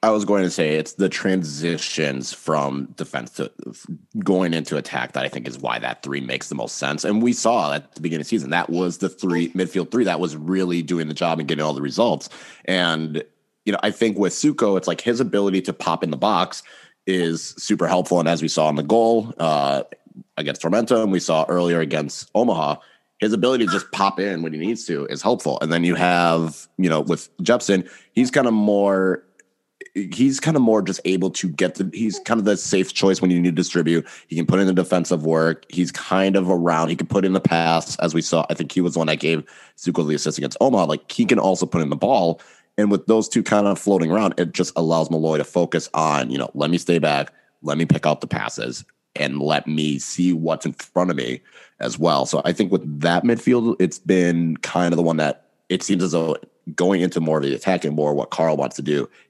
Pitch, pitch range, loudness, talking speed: 85 Hz, 80-95 Hz, -21 LUFS, 240 wpm